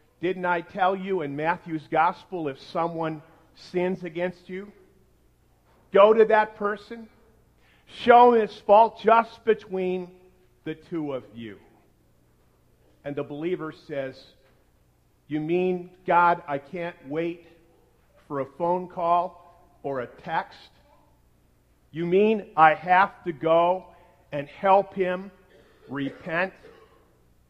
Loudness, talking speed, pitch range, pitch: -24 LUFS, 115 wpm, 145-185 Hz, 175 Hz